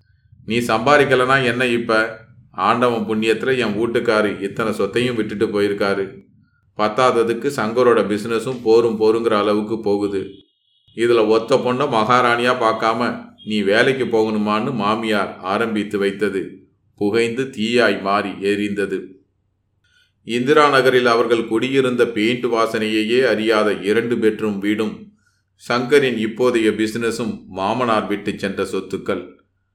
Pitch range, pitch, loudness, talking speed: 105-120 Hz, 110 Hz, -18 LUFS, 105 wpm